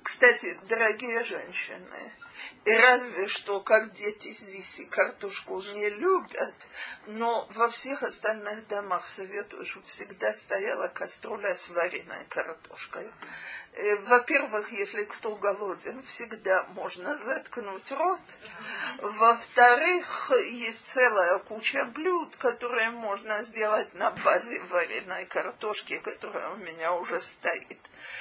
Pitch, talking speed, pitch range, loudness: 220 Hz, 110 wpm, 205-245 Hz, -28 LUFS